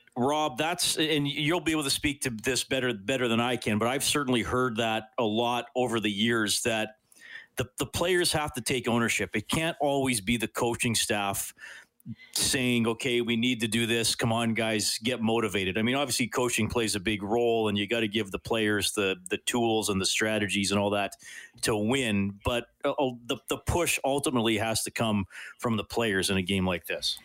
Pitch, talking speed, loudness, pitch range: 115 Hz, 205 wpm, -27 LUFS, 110-125 Hz